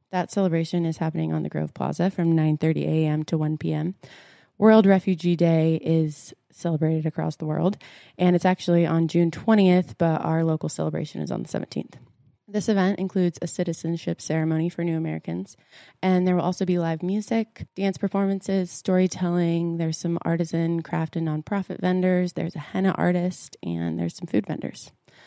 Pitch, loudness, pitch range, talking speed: 170 Hz, -24 LUFS, 160-185 Hz, 170 wpm